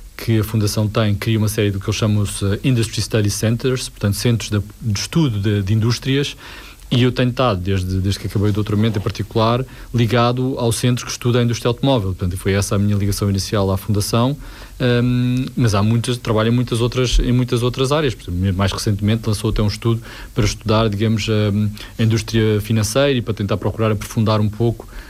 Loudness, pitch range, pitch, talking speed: -18 LUFS, 105-120 Hz, 110 Hz, 195 wpm